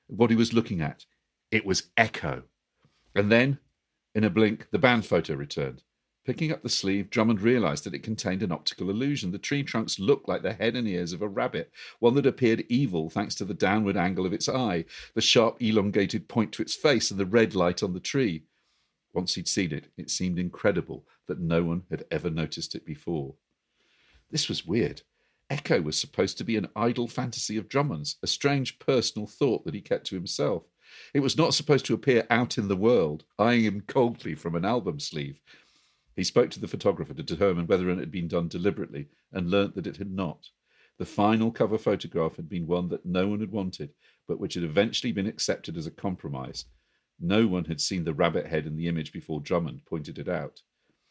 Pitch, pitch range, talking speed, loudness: 105 Hz, 90-120 Hz, 205 wpm, -27 LUFS